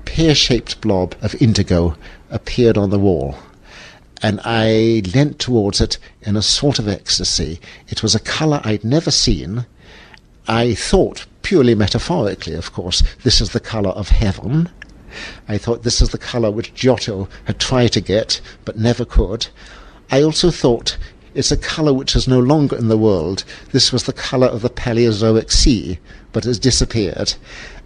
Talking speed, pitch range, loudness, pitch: 165 wpm, 100-125 Hz, -16 LUFS, 115 Hz